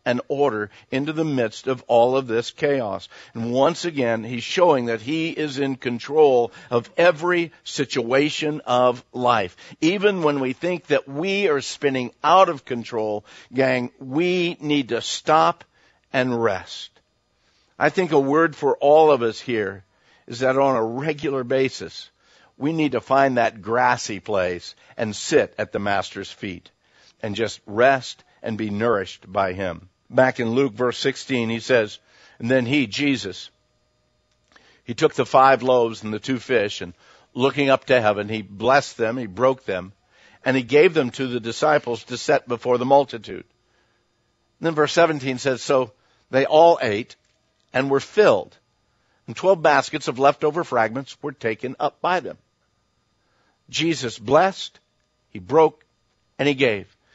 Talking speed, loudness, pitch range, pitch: 160 wpm, -21 LUFS, 120-150 Hz, 130 Hz